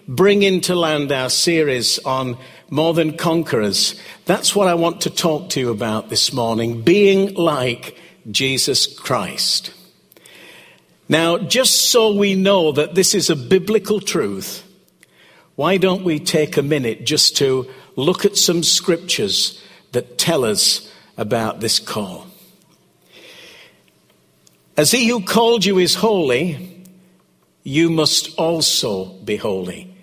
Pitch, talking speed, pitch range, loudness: 165 Hz, 130 wpm, 130-185 Hz, -16 LUFS